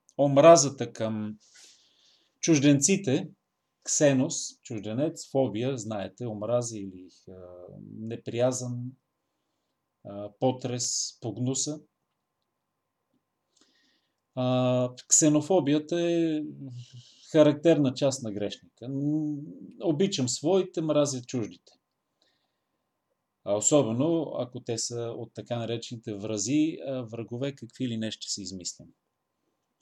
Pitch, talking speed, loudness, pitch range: 130 Hz, 75 wpm, -27 LUFS, 115-150 Hz